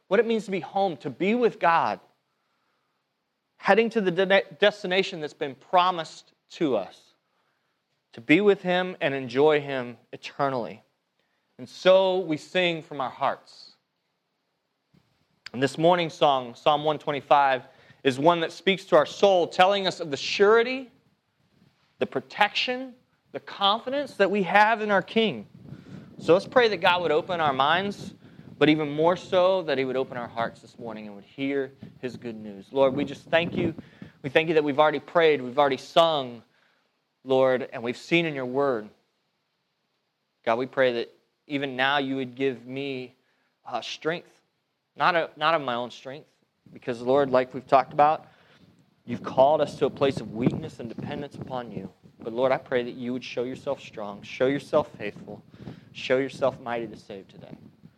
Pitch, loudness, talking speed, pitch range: 150 Hz, -25 LUFS, 175 wpm, 130-185 Hz